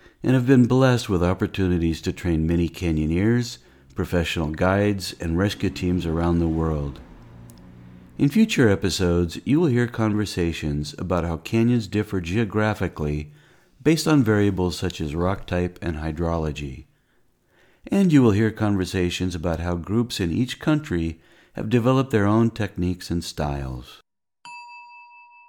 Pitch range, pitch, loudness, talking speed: 85-115 Hz, 90 Hz, -22 LUFS, 135 wpm